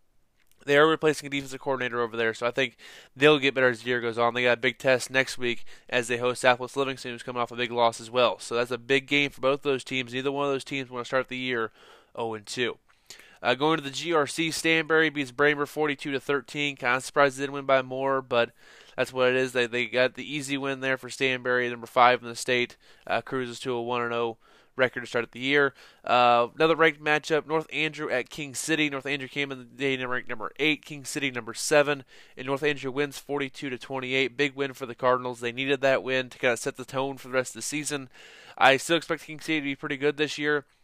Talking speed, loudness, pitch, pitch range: 245 wpm, -26 LUFS, 135 Hz, 125-145 Hz